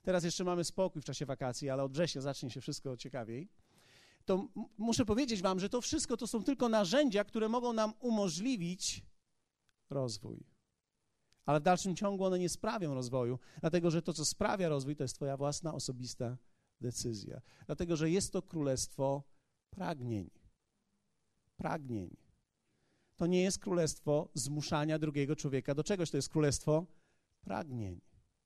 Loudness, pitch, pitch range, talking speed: -36 LUFS, 155 Hz, 135-190 Hz, 150 wpm